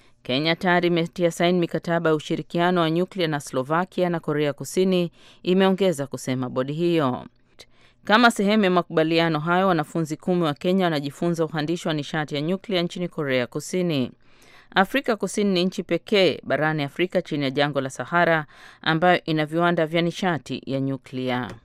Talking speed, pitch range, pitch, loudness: 150 wpm, 145-175 Hz, 165 Hz, -23 LUFS